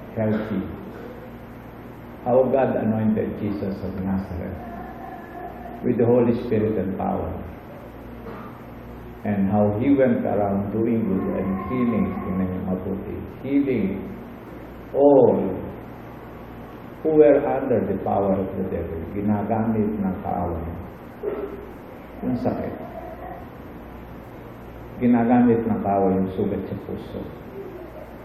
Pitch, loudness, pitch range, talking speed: 100 Hz, -23 LUFS, 95-120 Hz, 85 wpm